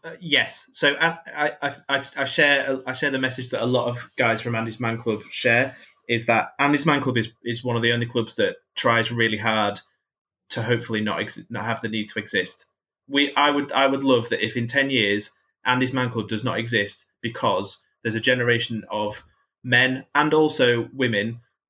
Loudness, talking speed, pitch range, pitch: -22 LUFS, 205 wpm, 115-135 Hz, 120 Hz